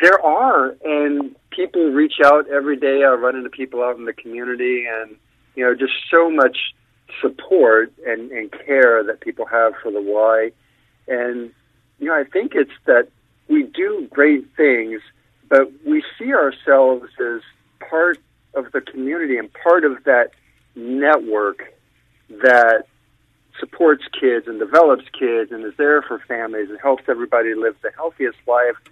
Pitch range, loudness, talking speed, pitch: 115-150 Hz, -17 LUFS, 155 wpm, 130 Hz